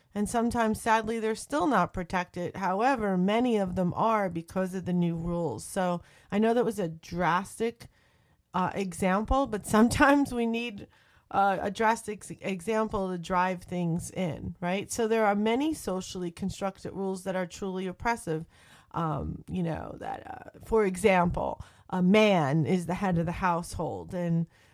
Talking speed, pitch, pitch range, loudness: 160 wpm, 190 Hz, 180-220 Hz, -29 LUFS